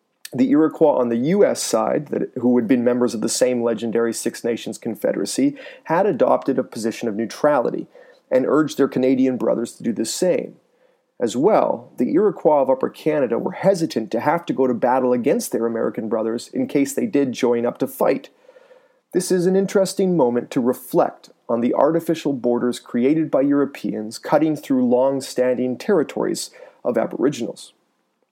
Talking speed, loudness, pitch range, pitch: 170 wpm, -20 LUFS, 120-190 Hz, 135 Hz